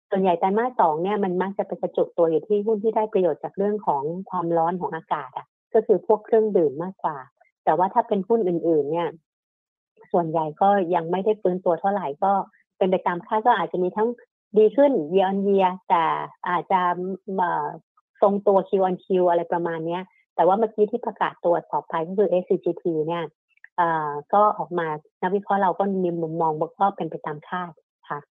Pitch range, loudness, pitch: 175-210 Hz, -23 LUFS, 185 Hz